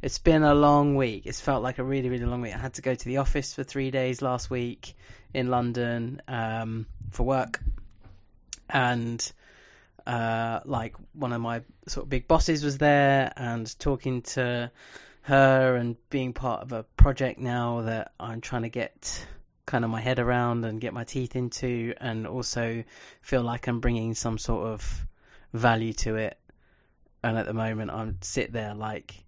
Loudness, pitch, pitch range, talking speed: -28 LUFS, 120 Hz, 115-130 Hz, 180 wpm